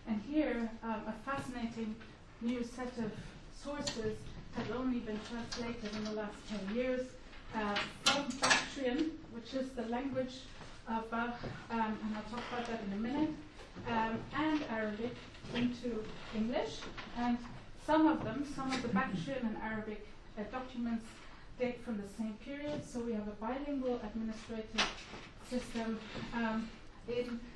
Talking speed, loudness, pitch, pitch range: 150 wpm, -38 LUFS, 235 Hz, 220-255 Hz